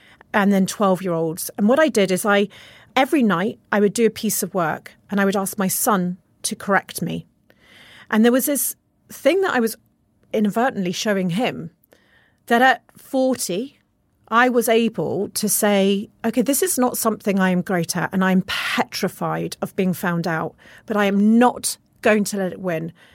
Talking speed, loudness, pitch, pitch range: 185 wpm, -20 LUFS, 205 Hz, 185-235 Hz